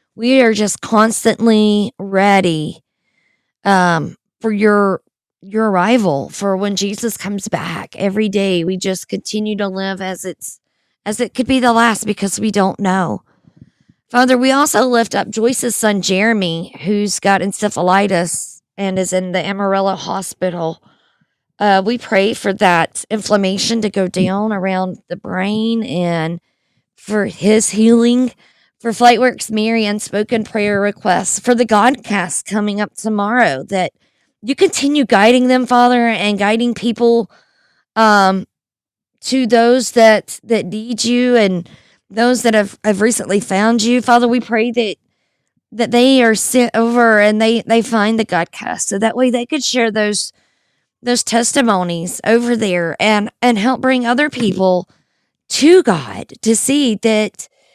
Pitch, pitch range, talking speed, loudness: 215 Hz, 195-235 Hz, 145 wpm, -14 LUFS